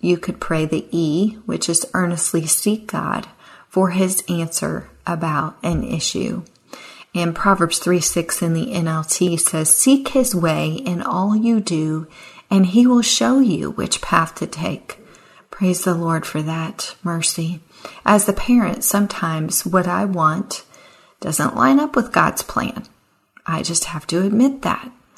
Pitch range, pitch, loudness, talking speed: 165-210 Hz, 180 Hz, -18 LUFS, 155 wpm